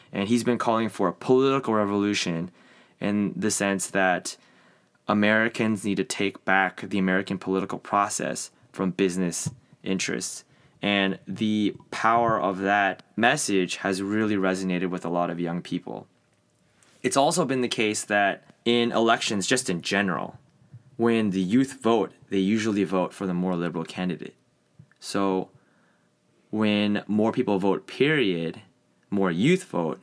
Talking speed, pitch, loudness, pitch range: 140 wpm, 100 Hz, -25 LUFS, 95-115 Hz